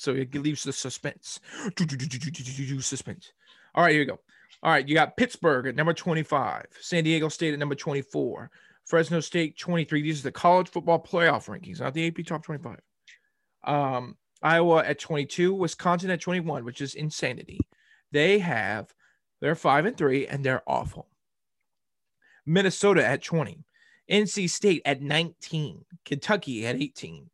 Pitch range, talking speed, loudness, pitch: 140-175 Hz, 150 wpm, -26 LUFS, 160 Hz